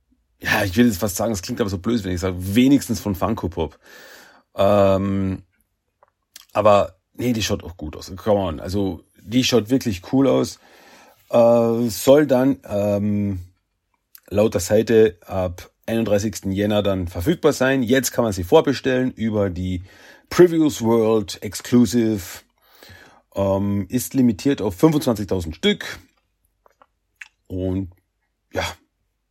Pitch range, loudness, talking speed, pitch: 95-120 Hz, -20 LUFS, 130 wpm, 105 Hz